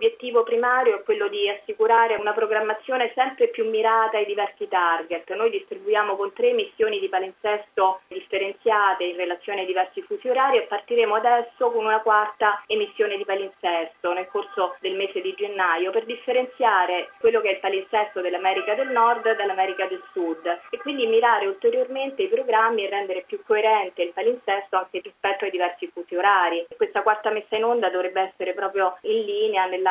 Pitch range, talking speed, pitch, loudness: 190-255 Hz, 170 wpm, 215 Hz, -23 LUFS